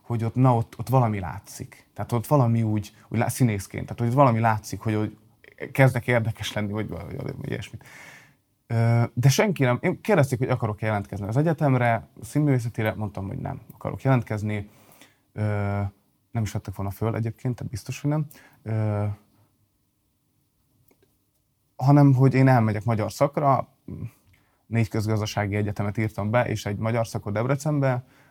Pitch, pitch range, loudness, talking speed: 115 Hz, 105-130 Hz, -24 LUFS, 150 wpm